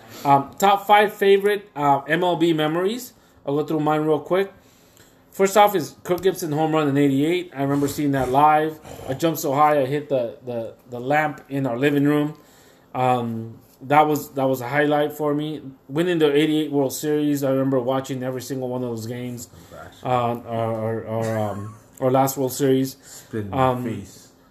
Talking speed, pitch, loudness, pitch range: 180 wpm, 140 Hz, -21 LUFS, 125-155 Hz